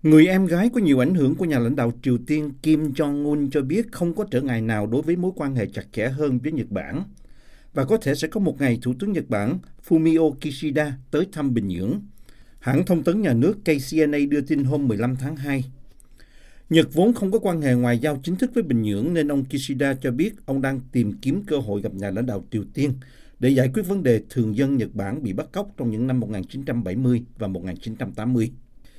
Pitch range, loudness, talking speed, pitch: 120-155 Hz, -23 LUFS, 230 wpm, 135 Hz